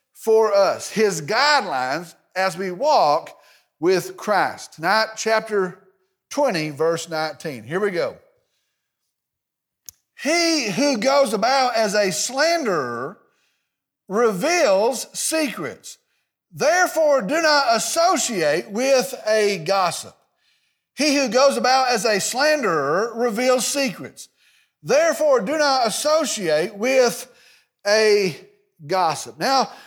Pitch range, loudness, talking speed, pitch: 200-285 Hz, -20 LUFS, 100 wpm, 240 Hz